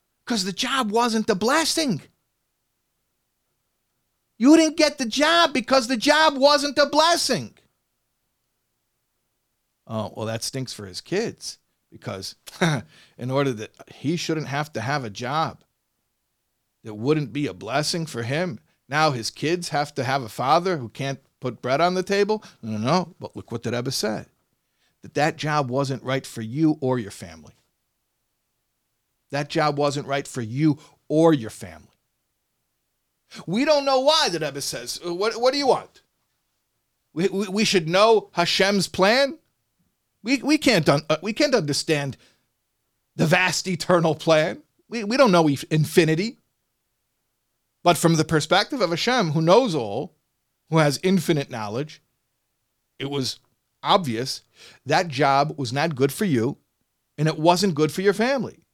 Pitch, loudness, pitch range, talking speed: 155 Hz, -22 LUFS, 130-195 Hz, 150 wpm